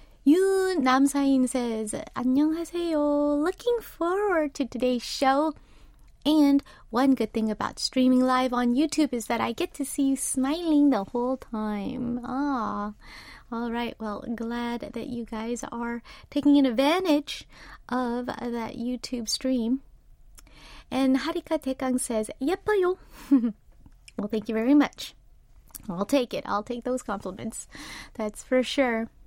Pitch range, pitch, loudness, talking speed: 235-290 Hz, 255 Hz, -26 LUFS, 130 wpm